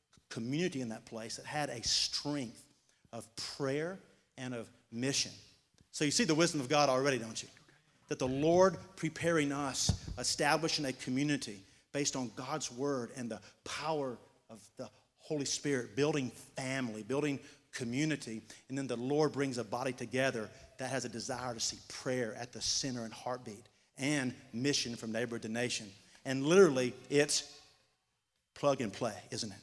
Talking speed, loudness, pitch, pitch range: 160 wpm, -35 LUFS, 130 Hz, 120-145 Hz